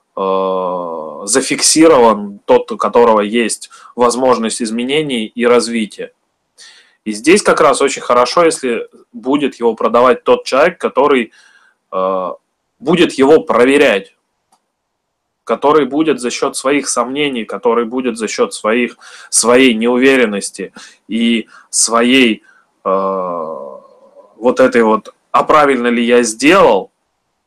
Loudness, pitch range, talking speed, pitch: -12 LUFS, 115-155 Hz, 110 wpm, 120 Hz